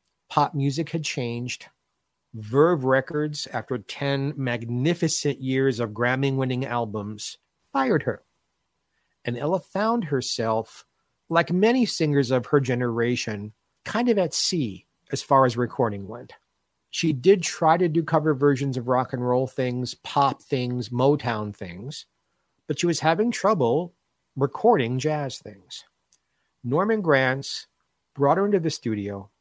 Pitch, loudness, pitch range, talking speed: 135 Hz, -24 LUFS, 120-160 Hz, 135 wpm